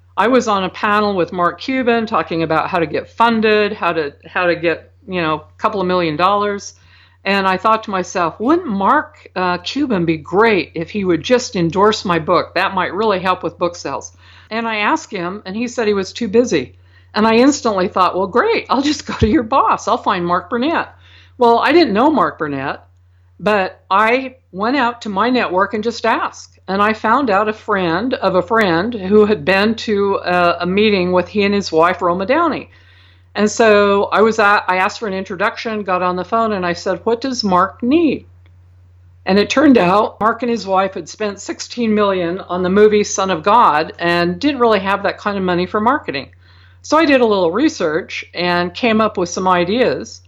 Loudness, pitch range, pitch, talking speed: -16 LUFS, 175-225 Hz, 195 Hz, 210 wpm